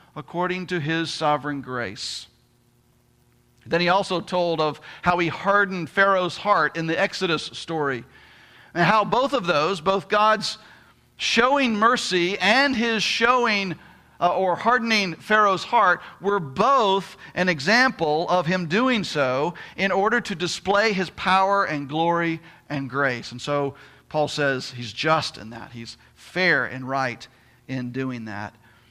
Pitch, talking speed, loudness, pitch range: 170 Hz, 145 wpm, -22 LUFS, 135-195 Hz